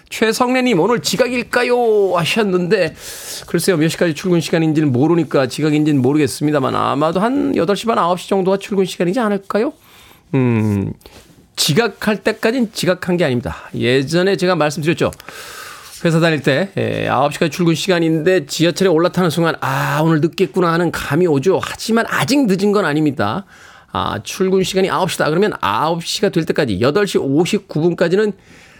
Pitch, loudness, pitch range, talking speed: 175 Hz, -16 LUFS, 155-200 Hz, 340 characters per minute